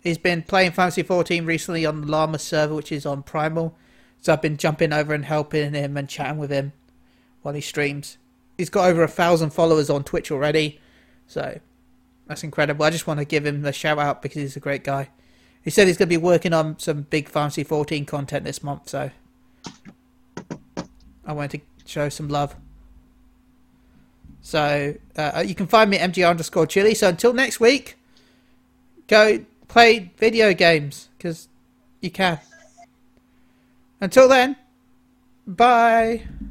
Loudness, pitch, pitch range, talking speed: -20 LUFS, 155 Hz, 145-180 Hz, 165 wpm